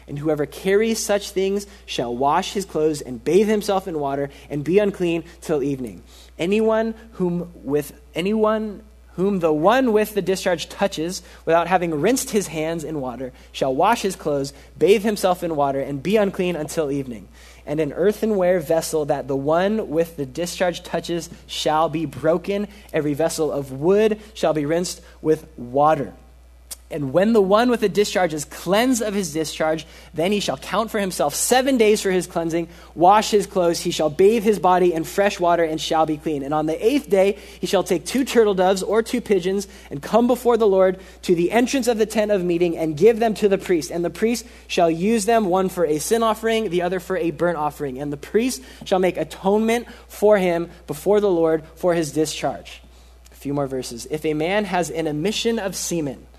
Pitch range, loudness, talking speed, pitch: 155-205 Hz, -21 LUFS, 200 wpm, 175 Hz